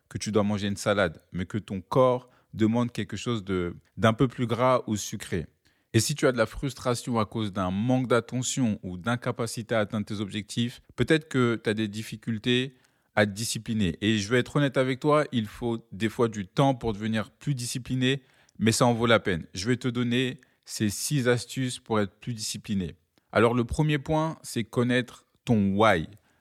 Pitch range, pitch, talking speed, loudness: 105-125 Hz, 115 Hz, 200 wpm, -27 LUFS